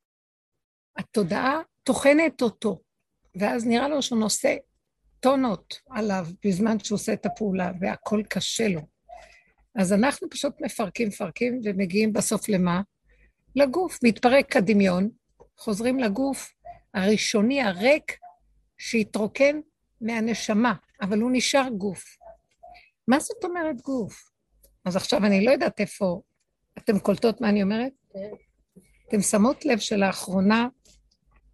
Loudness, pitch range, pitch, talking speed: -24 LUFS, 205-270 Hz, 225 Hz, 110 wpm